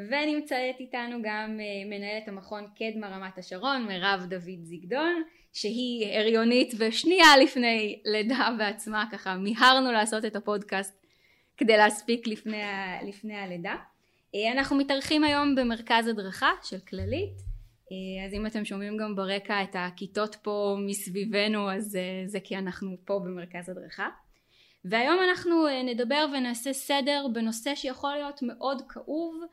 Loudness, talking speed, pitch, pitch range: -27 LUFS, 125 wpm, 215 Hz, 195-260 Hz